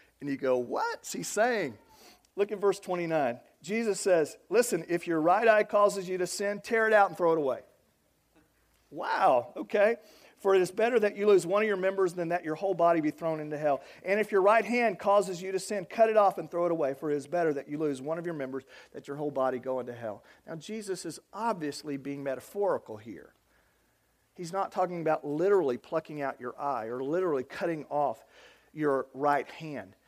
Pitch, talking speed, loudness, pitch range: 175 Hz, 215 wpm, -29 LUFS, 150-205 Hz